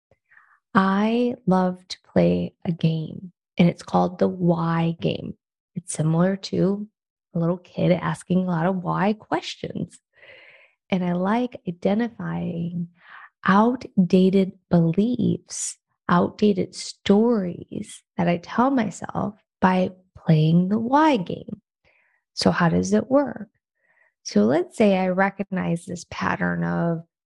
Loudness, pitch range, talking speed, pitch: -23 LUFS, 175-210 Hz, 120 wpm, 185 Hz